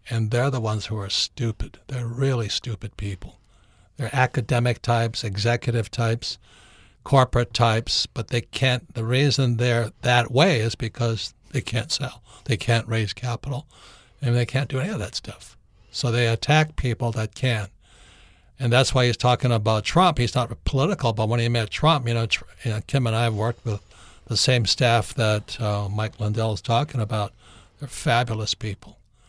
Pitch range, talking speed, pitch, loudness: 110-125 Hz, 180 wpm, 115 Hz, -23 LUFS